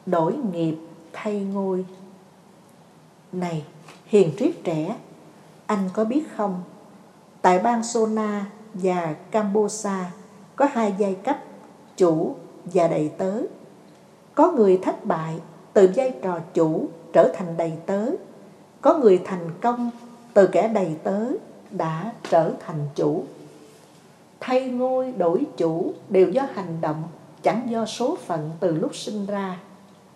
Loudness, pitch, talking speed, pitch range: -23 LUFS, 190 Hz, 130 wpm, 170-215 Hz